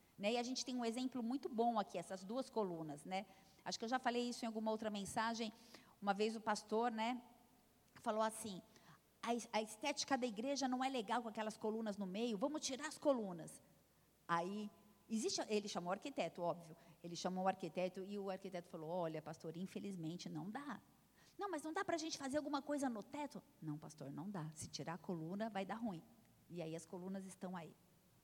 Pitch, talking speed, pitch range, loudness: 215 Hz, 200 wpm, 185-240 Hz, -44 LUFS